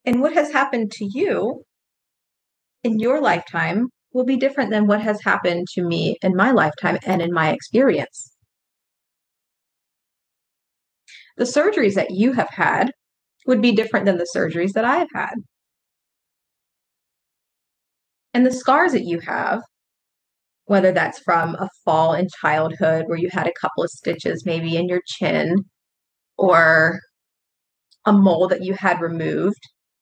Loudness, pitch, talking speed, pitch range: -19 LUFS, 195 Hz, 145 wpm, 175-245 Hz